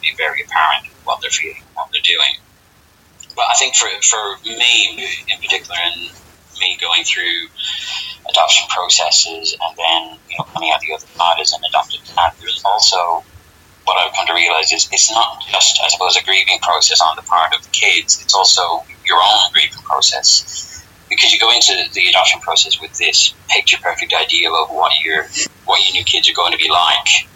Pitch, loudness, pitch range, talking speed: 85 Hz, -12 LUFS, 80-115 Hz, 190 wpm